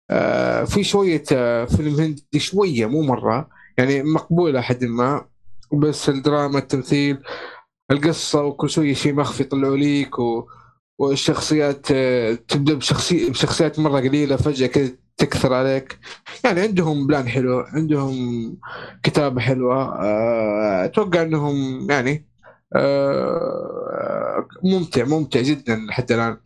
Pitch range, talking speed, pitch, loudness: 125-155 Hz, 110 wpm, 140 Hz, -20 LUFS